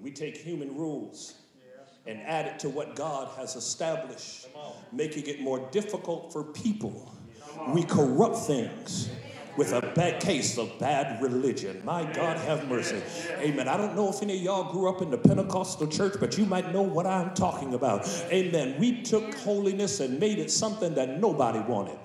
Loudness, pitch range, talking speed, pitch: -29 LUFS, 150-200 Hz, 175 wpm, 175 Hz